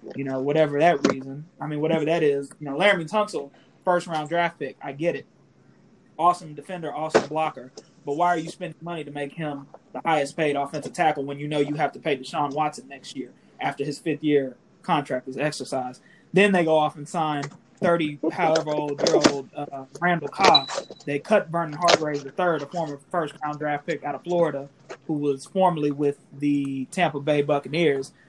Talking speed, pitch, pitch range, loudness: 200 wpm, 150 Hz, 140-170 Hz, -24 LUFS